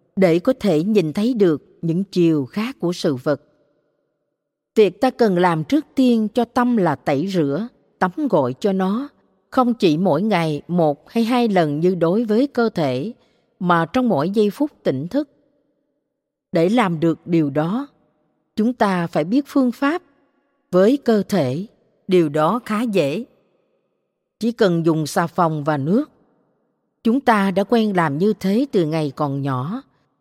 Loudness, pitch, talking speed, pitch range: -19 LUFS, 200 Hz, 165 wpm, 165-245 Hz